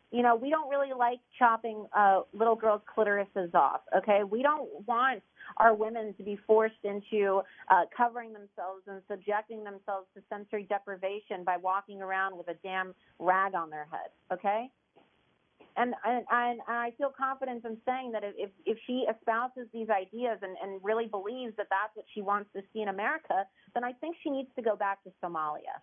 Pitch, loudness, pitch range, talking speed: 215 Hz, -31 LUFS, 195-240 Hz, 185 wpm